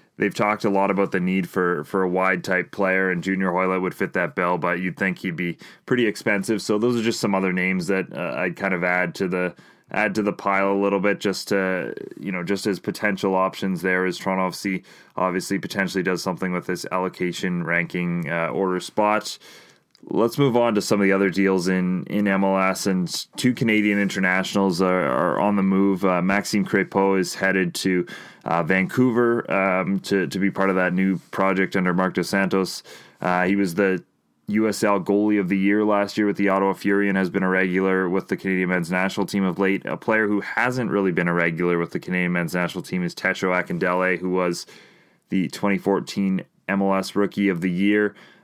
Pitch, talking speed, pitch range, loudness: 95 Hz, 205 wpm, 90-100 Hz, -22 LUFS